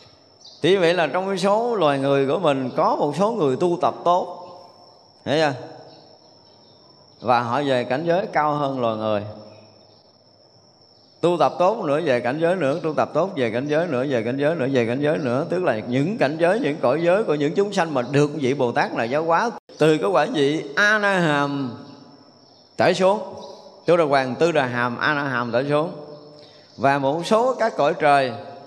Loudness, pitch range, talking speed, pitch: -21 LUFS, 130-170 Hz, 195 wpm, 145 Hz